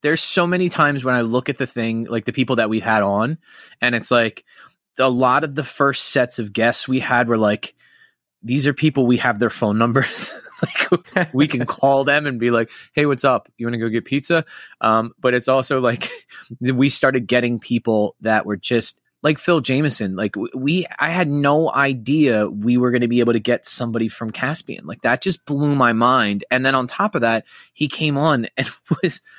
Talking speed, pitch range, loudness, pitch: 215 wpm, 115-145 Hz, -19 LUFS, 125 Hz